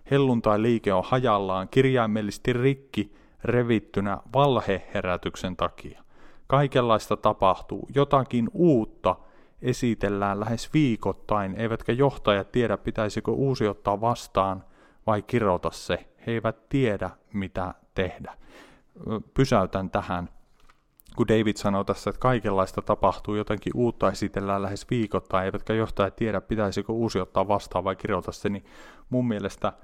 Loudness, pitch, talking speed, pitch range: -26 LUFS, 105 Hz, 115 wpm, 100-120 Hz